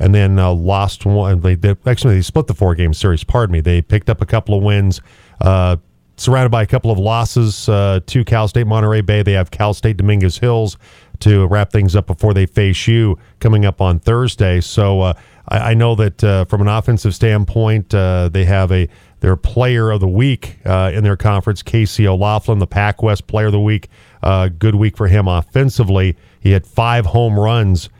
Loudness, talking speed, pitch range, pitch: -14 LUFS, 210 wpm, 95-110 Hz, 105 Hz